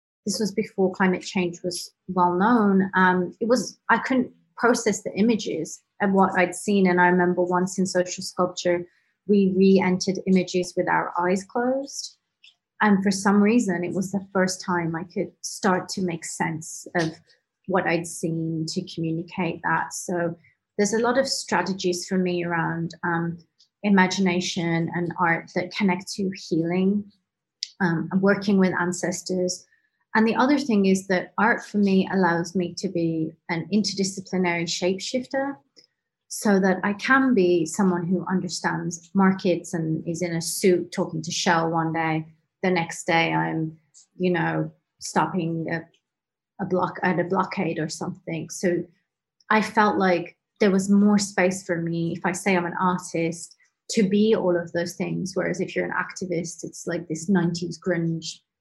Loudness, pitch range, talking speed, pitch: -24 LUFS, 170-195 Hz, 165 wpm, 180 Hz